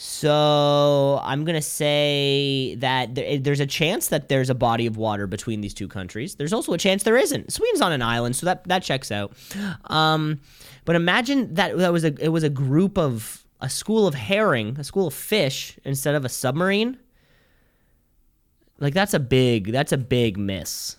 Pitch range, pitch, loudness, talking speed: 125-175 Hz, 145 Hz, -22 LUFS, 185 wpm